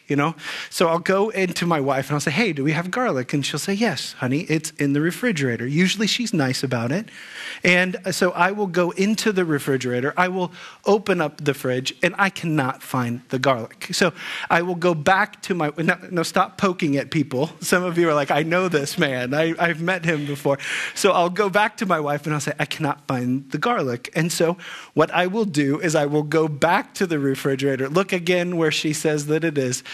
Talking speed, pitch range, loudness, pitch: 230 wpm, 145-185 Hz, -21 LUFS, 160 Hz